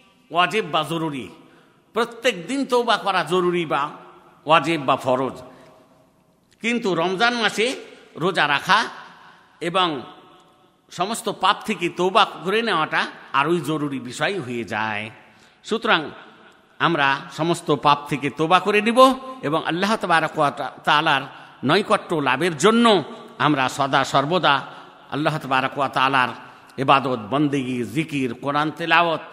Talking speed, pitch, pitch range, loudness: 110 wpm, 155 Hz, 135-185 Hz, -20 LUFS